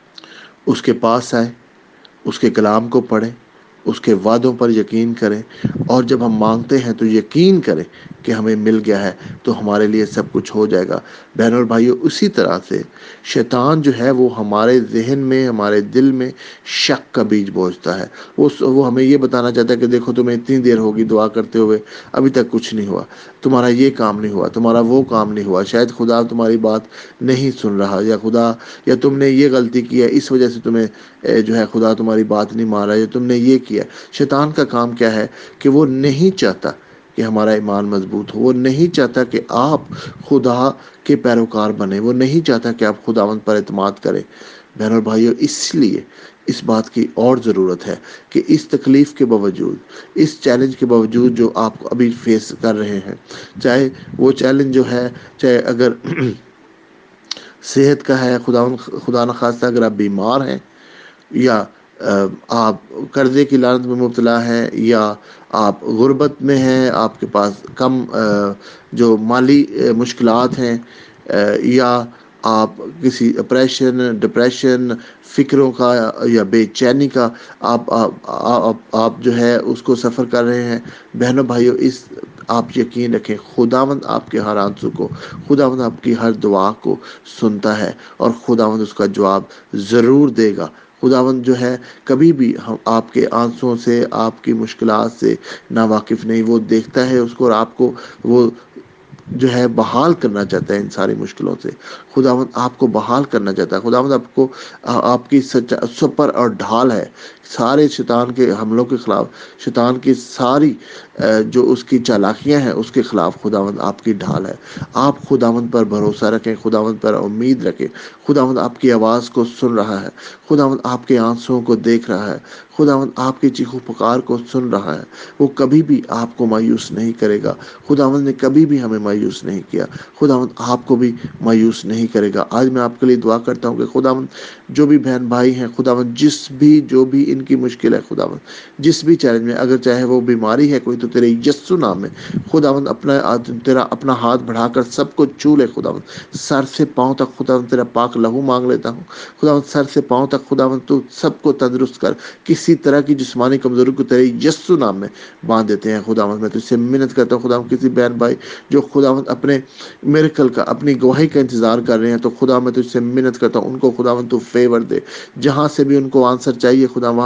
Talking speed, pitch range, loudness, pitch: 190 wpm, 115-130 Hz, -14 LUFS, 120 Hz